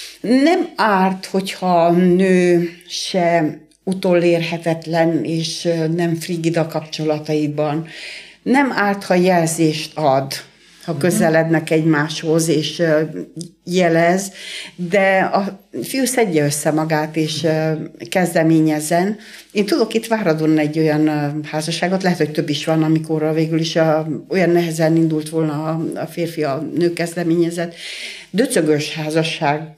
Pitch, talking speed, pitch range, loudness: 165 Hz, 115 wpm, 155-180 Hz, -17 LUFS